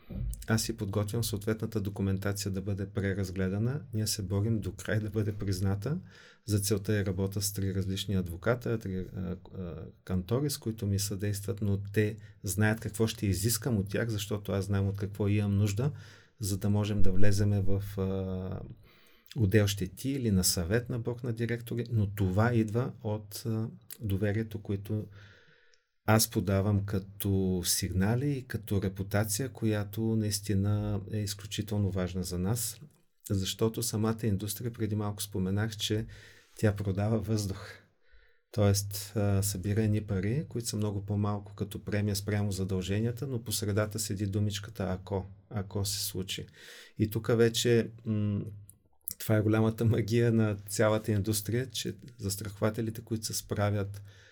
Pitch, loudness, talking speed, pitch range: 105 Hz, -32 LUFS, 145 wpm, 100-110 Hz